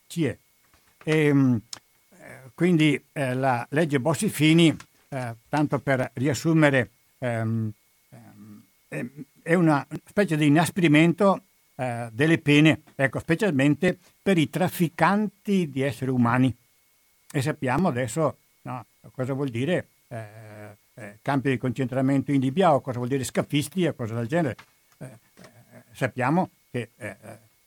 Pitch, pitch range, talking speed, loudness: 140 Hz, 125-160 Hz, 125 wpm, -24 LUFS